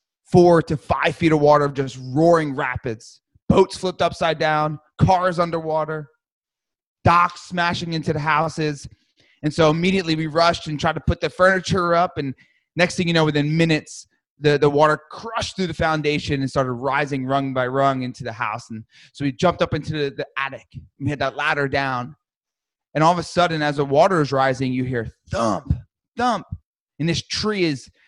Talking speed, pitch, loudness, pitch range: 190 wpm, 155 Hz, -20 LUFS, 140-170 Hz